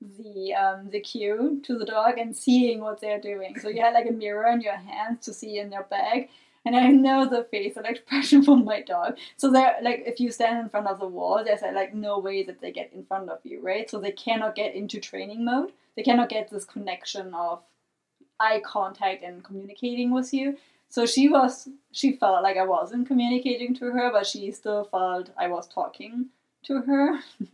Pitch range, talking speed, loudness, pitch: 205-255 Hz, 215 wpm, -25 LUFS, 225 Hz